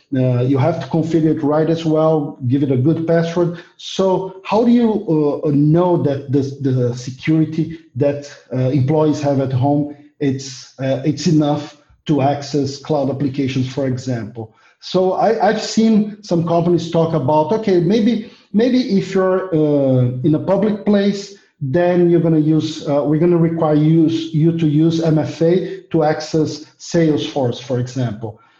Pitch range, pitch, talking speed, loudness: 140-175 Hz, 155 Hz, 165 wpm, -17 LUFS